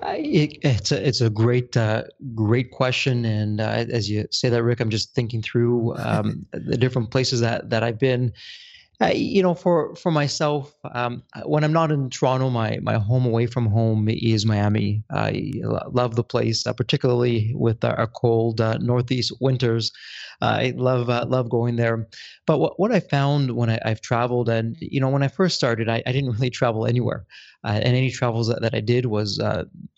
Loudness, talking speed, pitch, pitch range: -22 LUFS, 200 wpm, 120 Hz, 115-130 Hz